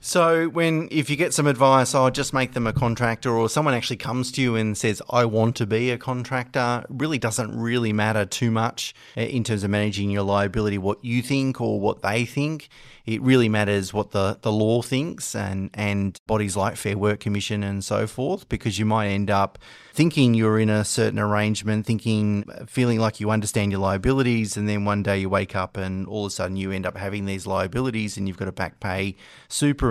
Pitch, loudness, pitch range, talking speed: 110 Hz, -23 LUFS, 100-125 Hz, 215 wpm